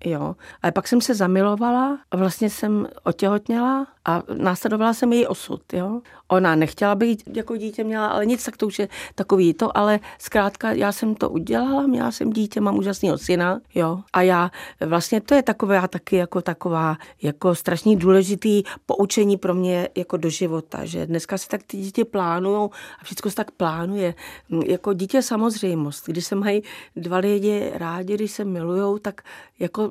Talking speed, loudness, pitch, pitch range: 175 wpm, -22 LUFS, 200 Hz, 180-215 Hz